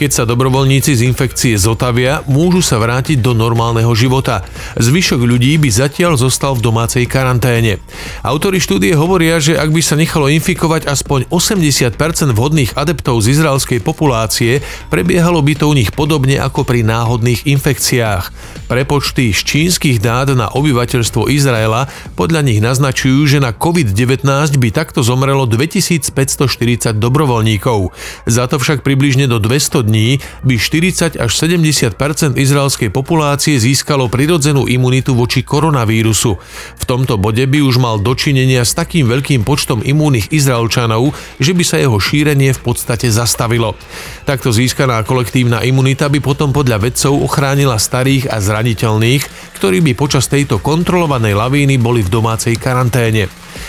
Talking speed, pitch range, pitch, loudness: 140 wpm, 120-145 Hz, 135 Hz, -12 LUFS